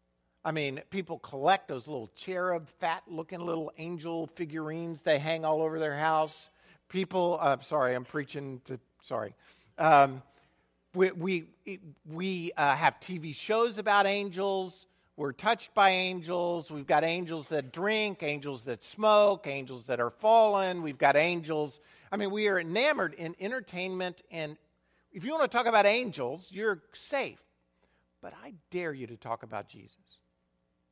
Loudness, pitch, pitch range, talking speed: -30 LUFS, 165 Hz, 145-190 Hz, 155 wpm